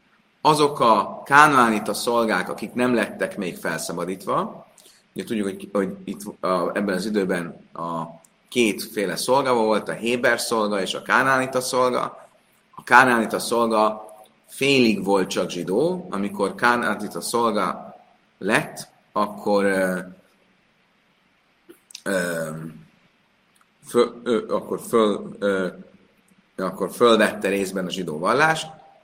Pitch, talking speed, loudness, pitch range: 110 Hz, 110 wpm, -21 LUFS, 95-125 Hz